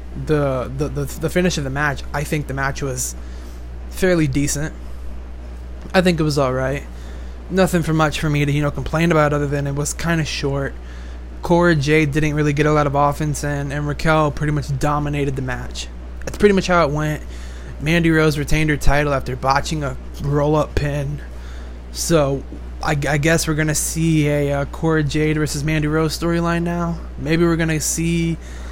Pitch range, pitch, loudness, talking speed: 135-155 Hz, 145 Hz, -19 LUFS, 190 wpm